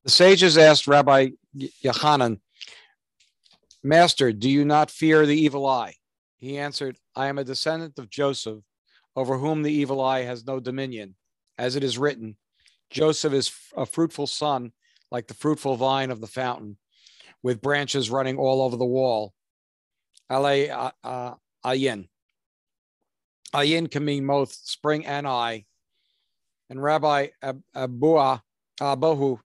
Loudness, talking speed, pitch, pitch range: -22 LUFS, 145 wpm, 135 Hz, 125-145 Hz